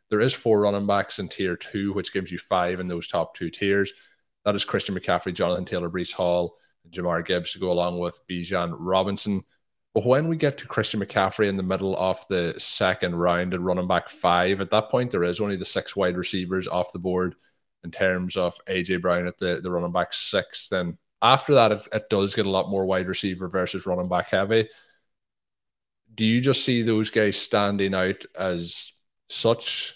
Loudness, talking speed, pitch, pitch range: -24 LUFS, 205 wpm, 95 Hz, 90-100 Hz